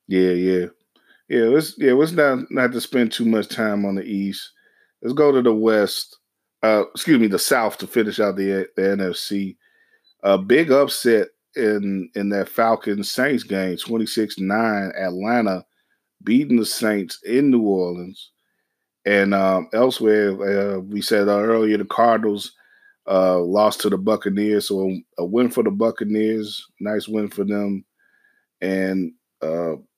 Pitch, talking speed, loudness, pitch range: 105 Hz, 150 wpm, -20 LUFS, 95-115 Hz